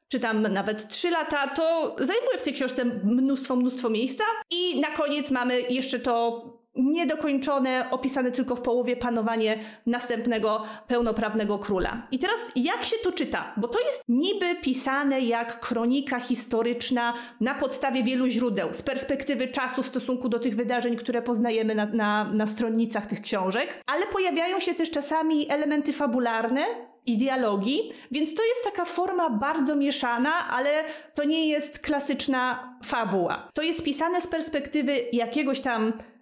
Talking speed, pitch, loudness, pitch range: 150 wpm, 255 Hz, -26 LUFS, 235-295 Hz